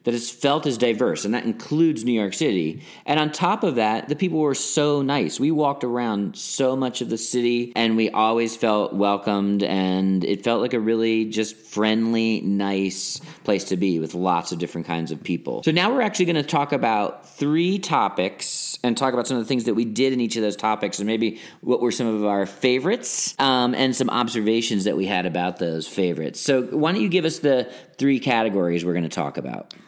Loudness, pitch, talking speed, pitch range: -22 LUFS, 115 Hz, 215 wpm, 100-140 Hz